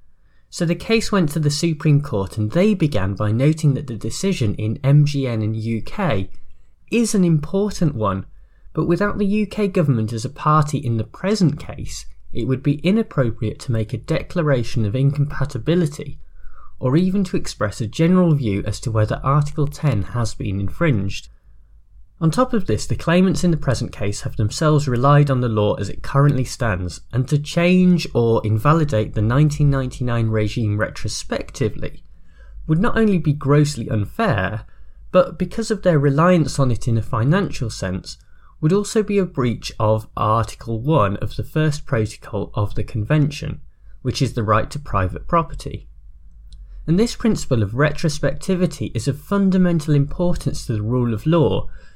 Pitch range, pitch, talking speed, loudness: 110-165 Hz, 135 Hz, 165 wpm, -20 LUFS